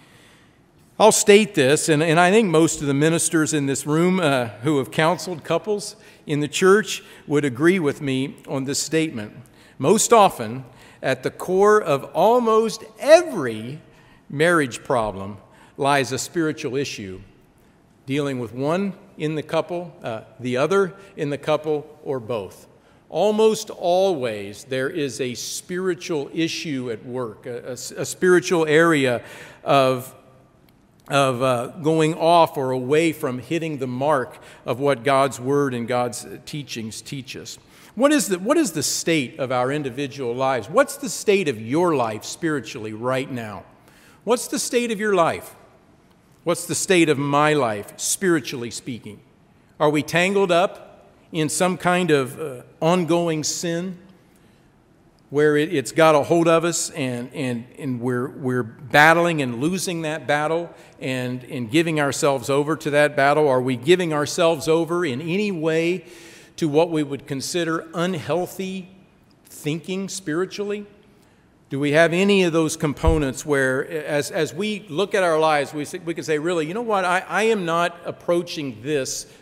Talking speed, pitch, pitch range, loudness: 155 wpm, 155 Hz, 135-175 Hz, -21 LUFS